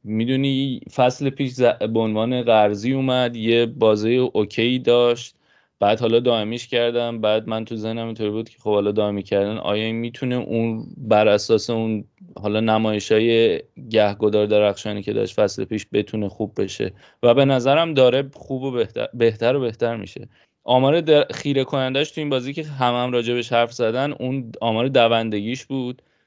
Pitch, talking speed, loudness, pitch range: 115 Hz, 170 wpm, -20 LUFS, 110-125 Hz